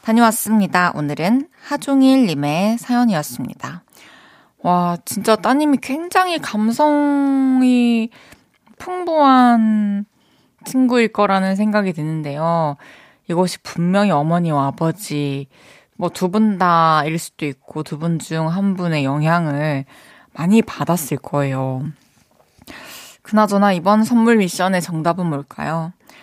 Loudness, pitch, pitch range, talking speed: -17 LUFS, 195 Hz, 160-235 Hz, 240 characters per minute